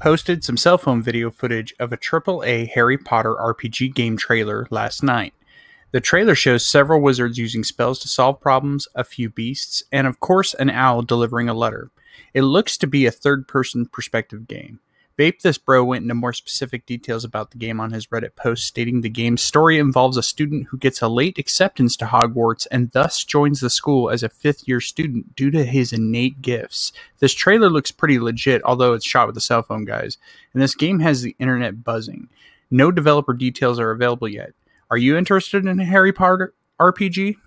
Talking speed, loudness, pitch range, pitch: 200 wpm, -18 LUFS, 120-145 Hz, 125 Hz